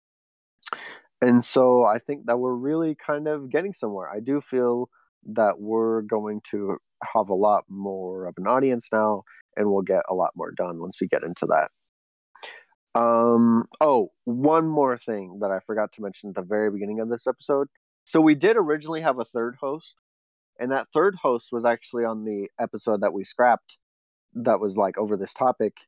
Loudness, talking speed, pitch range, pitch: -24 LUFS, 190 wpm, 100-130 Hz, 115 Hz